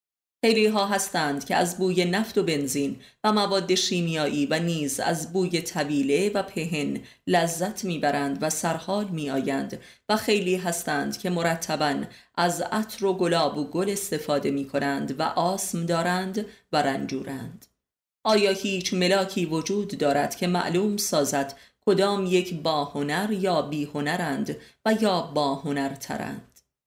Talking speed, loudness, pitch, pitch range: 130 wpm, -25 LUFS, 175 Hz, 145-195 Hz